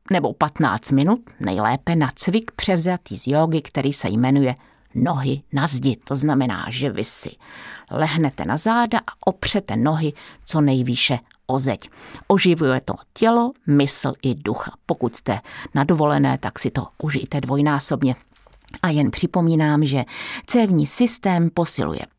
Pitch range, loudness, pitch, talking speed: 130-170 Hz, -20 LUFS, 145 Hz, 140 wpm